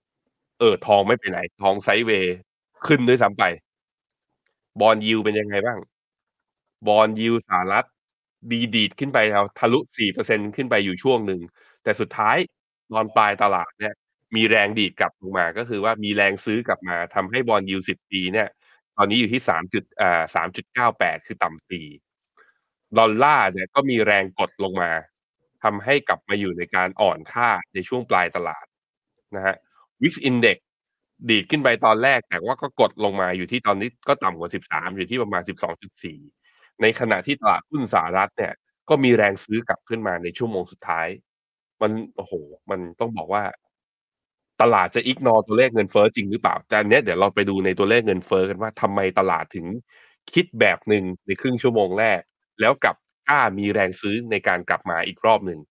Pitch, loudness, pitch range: 105 Hz, -21 LUFS, 95-115 Hz